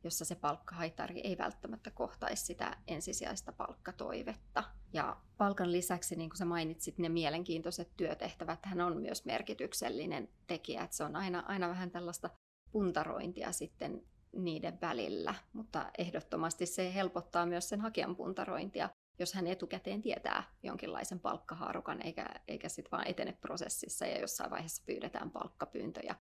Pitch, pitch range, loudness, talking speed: 175 Hz, 165-185 Hz, -40 LUFS, 135 wpm